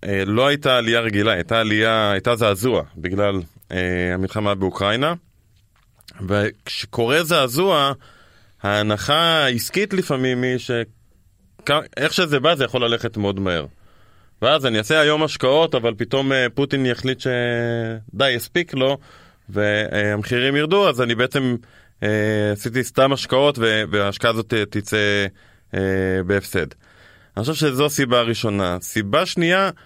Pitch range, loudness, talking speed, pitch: 100-130 Hz, -19 LUFS, 120 wpm, 115 Hz